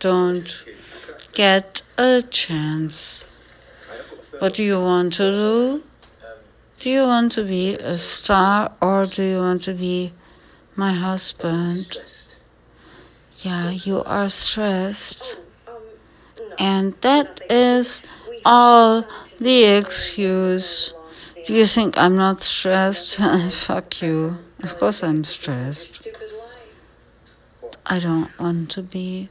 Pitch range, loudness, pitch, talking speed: 175-225 Hz, -18 LUFS, 190 Hz, 105 wpm